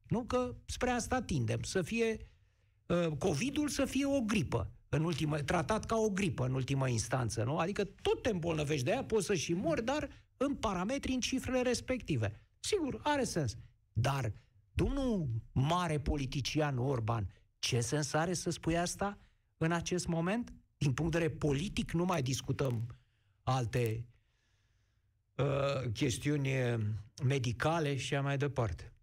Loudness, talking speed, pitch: -35 LUFS, 145 wpm, 150 Hz